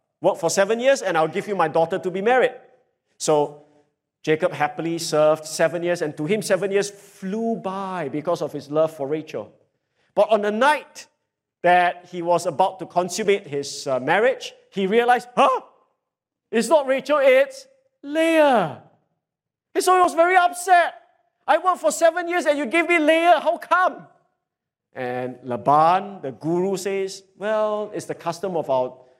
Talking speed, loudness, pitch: 165 wpm, -21 LUFS, 195 Hz